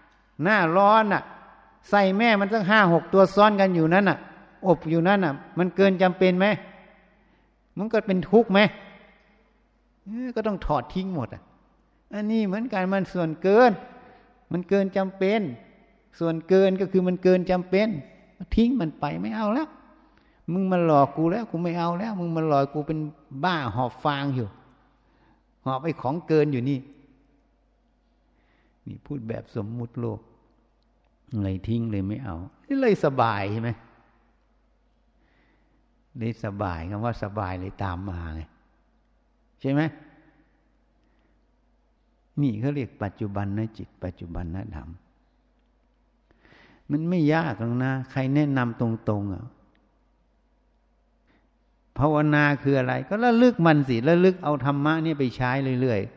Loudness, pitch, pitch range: -24 LUFS, 155 Hz, 120-195 Hz